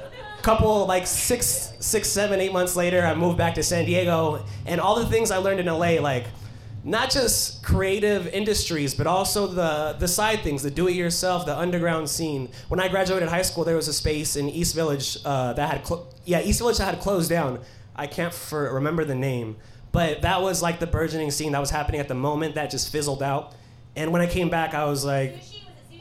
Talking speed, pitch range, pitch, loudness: 210 wpm, 140-180 Hz, 160 Hz, -24 LUFS